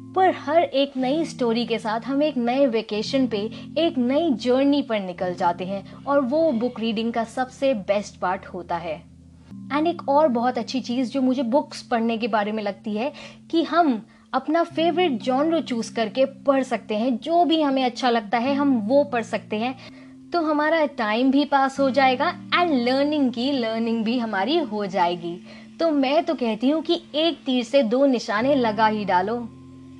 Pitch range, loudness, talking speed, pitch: 220-285 Hz, -22 LUFS, 190 wpm, 255 Hz